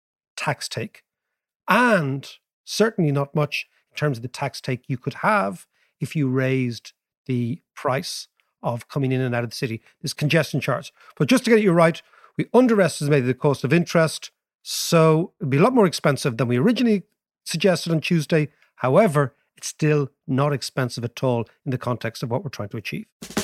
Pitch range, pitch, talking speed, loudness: 130-175 Hz, 150 Hz, 185 wpm, -22 LUFS